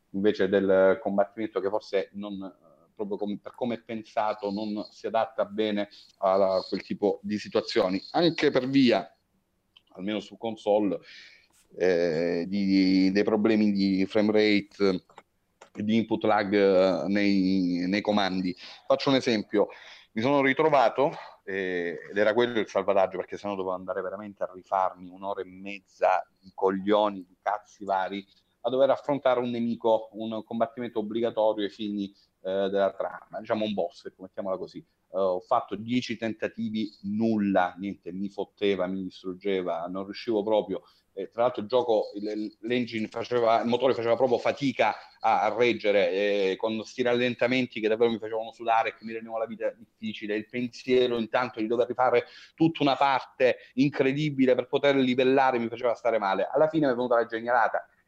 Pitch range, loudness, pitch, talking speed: 100-120 Hz, -27 LUFS, 105 Hz, 160 wpm